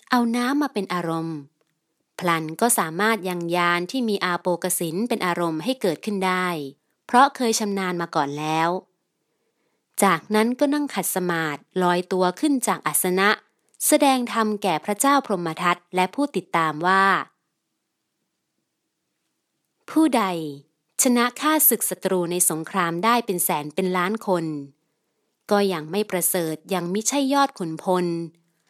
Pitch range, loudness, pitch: 170-225 Hz, -22 LUFS, 185 Hz